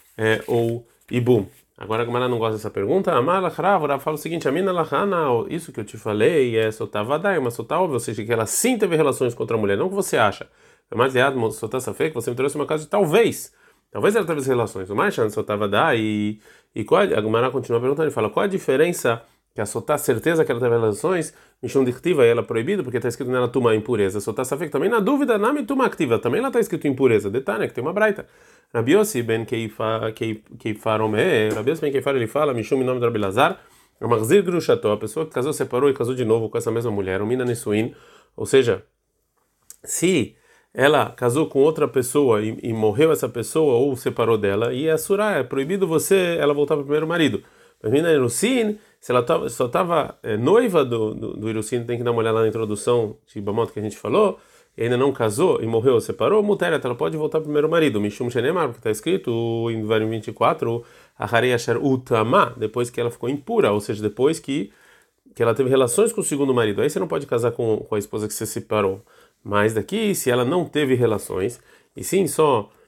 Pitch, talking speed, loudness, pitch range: 125 Hz, 220 wpm, -21 LUFS, 110-155 Hz